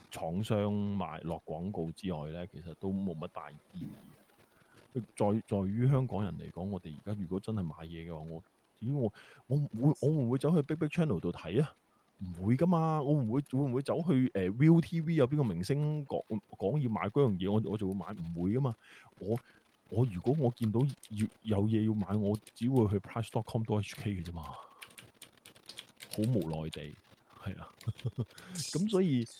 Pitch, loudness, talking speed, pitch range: 110 Hz, -33 LUFS, 300 characters per minute, 95-135 Hz